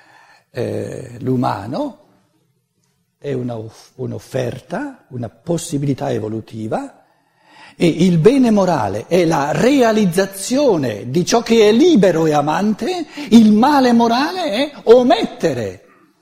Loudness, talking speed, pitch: -15 LUFS, 100 wpm, 185 Hz